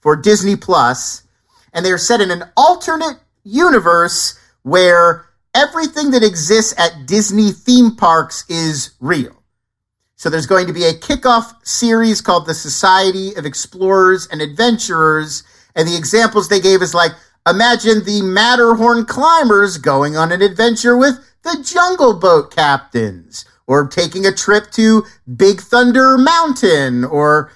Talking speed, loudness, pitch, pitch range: 140 wpm, -12 LUFS, 190 Hz, 160-230 Hz